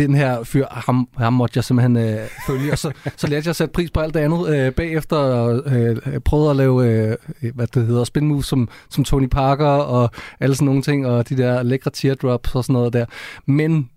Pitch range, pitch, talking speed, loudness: 125-145 Hz, 135 Hz, 230 wpm, -19 LUFS